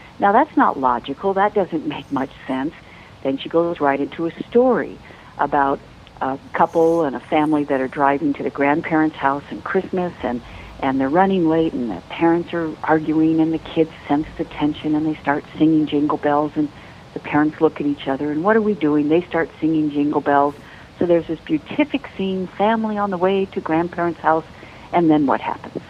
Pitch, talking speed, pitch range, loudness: 155 Hz, 200 wpm, 145-170 Hz, -20 LUFS